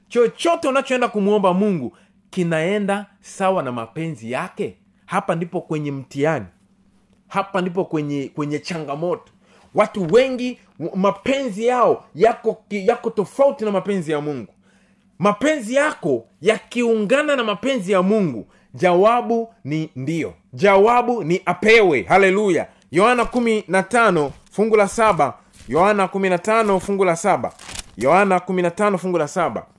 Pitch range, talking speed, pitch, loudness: 170-225 Hz, 110 wpm, 200 Hz, -19 LUFS